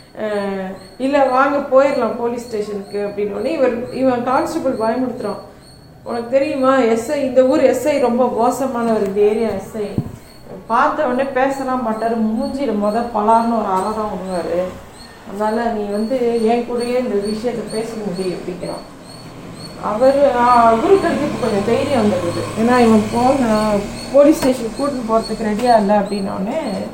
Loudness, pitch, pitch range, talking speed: -17 LUFS, 230 Hz, 210-260 Hz, 125 wpm